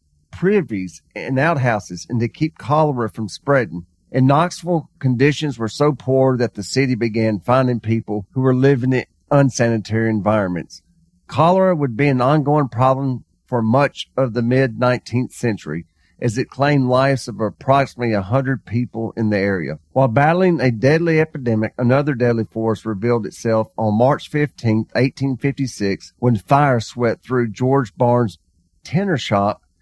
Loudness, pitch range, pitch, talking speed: -18 LUFS, 110-140 Hz, 125 Hz, 155 wpm